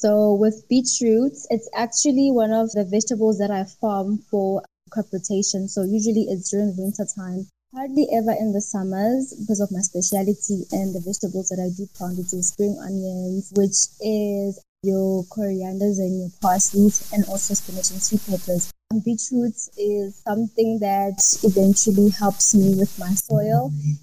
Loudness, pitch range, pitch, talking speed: -21 LUFS, 190-215 Hz, 200 Hz, 160 wpm